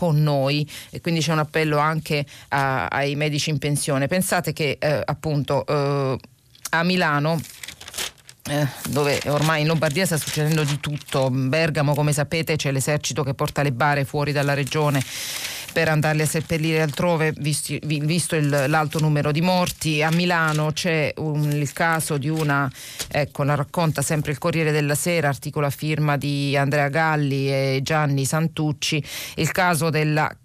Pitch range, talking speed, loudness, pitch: 140-160 Hz, 160 wpm, -22 LUFS, 150 Hz